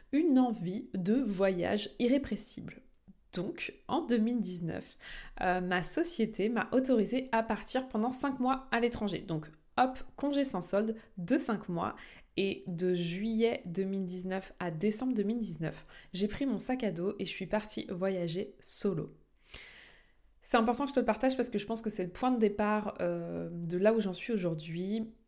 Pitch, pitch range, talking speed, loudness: 210 Hz, 185-240 Hz, 170 wpm, -33 LUFS